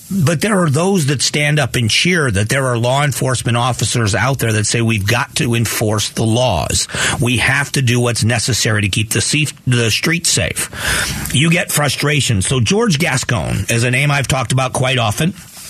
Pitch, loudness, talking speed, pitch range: 130 Hz, -14 LUFS, 190 wpm, 115-145 Hz